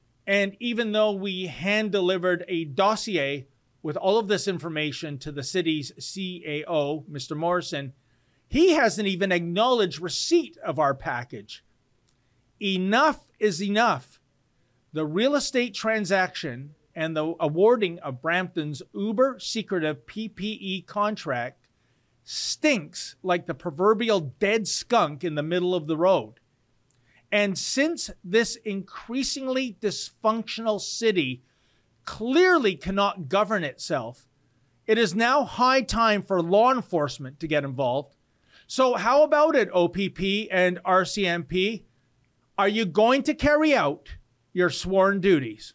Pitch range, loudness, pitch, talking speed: 145-215 Hz, -24 LUFS, 185 Hz, 120 wpm